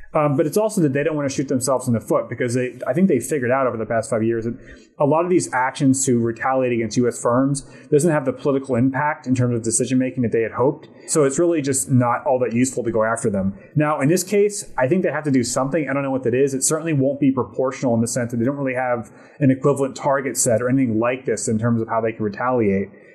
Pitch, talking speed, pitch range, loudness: 130 Hz, 280 wpm, 120-145 Hz, -20 LUFS